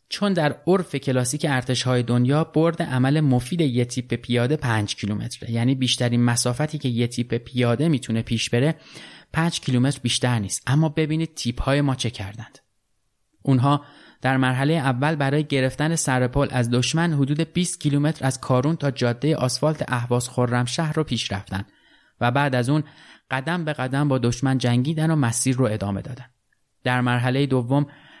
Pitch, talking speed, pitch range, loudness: 130 Hz, 165 wpm, 120-150 Hz, -22 LUFS